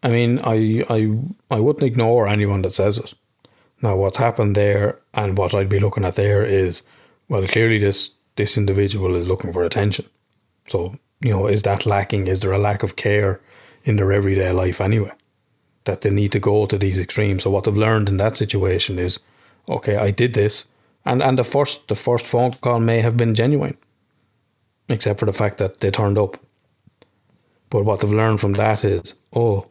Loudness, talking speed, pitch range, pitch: -19 LUFS, 195 wpm, 100-115 Hz, 105 Hz